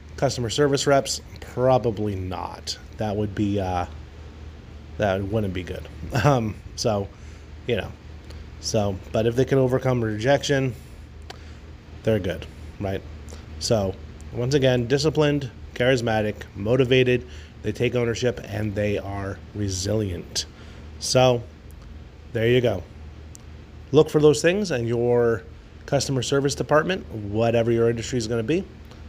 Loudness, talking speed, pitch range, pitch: -23 LUFS, 125 wpm, 80-125 Hz, 105 Hz